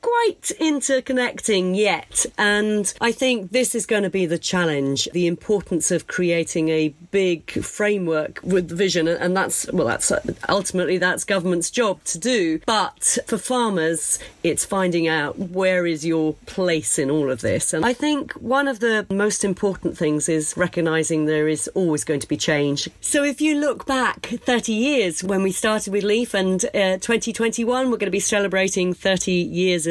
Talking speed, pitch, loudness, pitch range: 175 wpm, 190 Hz, -21 LUFS, 170-230 Hz